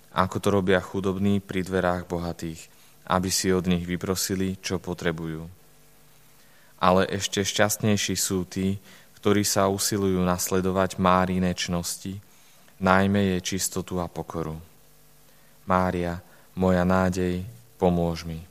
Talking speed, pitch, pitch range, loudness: 115 wpm, 95 Hz, 90-95 Hz, -25 LUFS